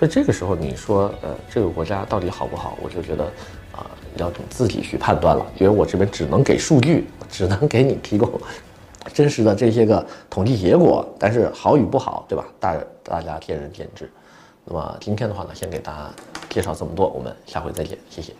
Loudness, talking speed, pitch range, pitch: -20 LUFS, 315 characters per minute, 90-110 Hz, 100 Hz